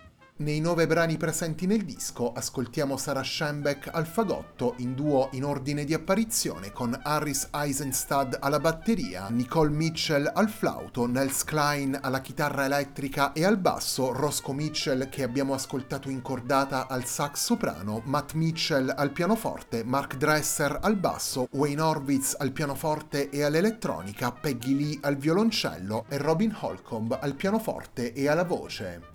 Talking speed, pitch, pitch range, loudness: 145 wpm, 145 Hz, 135-160 Hz, -28 LUFS